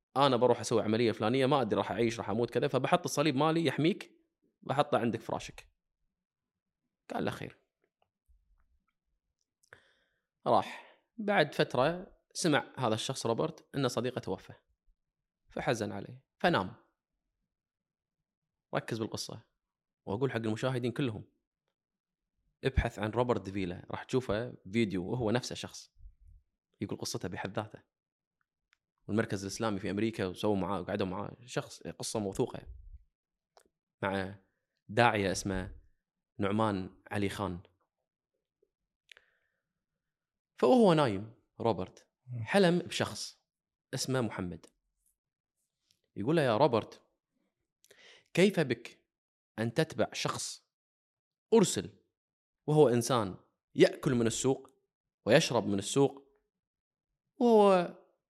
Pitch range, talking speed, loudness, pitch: 100-140 Hz, 100 wpm, -32 LUFS, 115 Hz